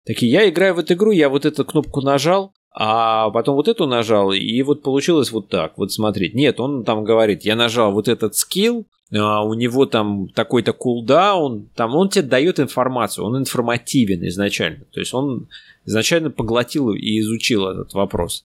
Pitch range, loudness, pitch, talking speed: 110-145 Hz, -18 LUFS, 120 Hz, 175 wpm